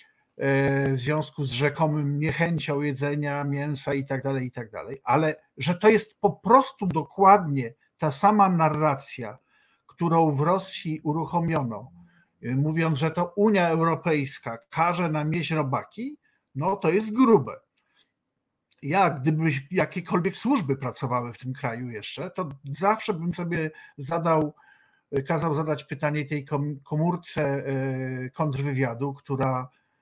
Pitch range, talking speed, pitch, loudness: 140-175 Hz, 120 wpm, 155 Hz, -25 LUFS